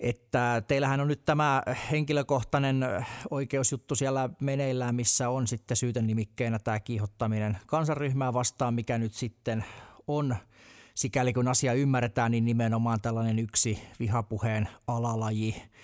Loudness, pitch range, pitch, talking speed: -29 LUFS, 115-135 Hz, 120 Hz, 120 wpm